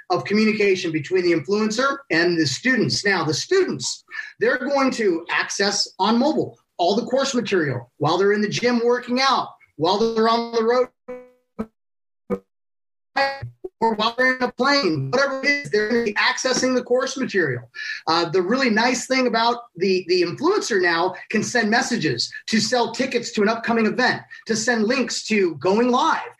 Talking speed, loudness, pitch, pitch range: 165 wpm, -20 LUFS, 230 Hz, 195-255 Hz